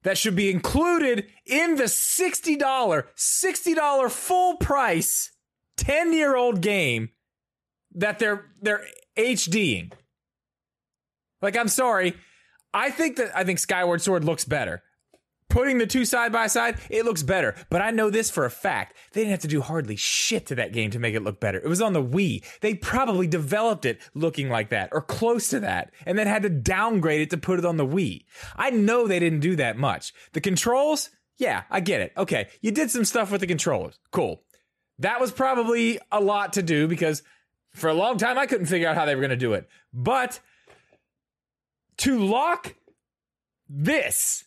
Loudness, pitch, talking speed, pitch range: -24 LUFS, 205 Hz, 190 wpm, 160-245 Hz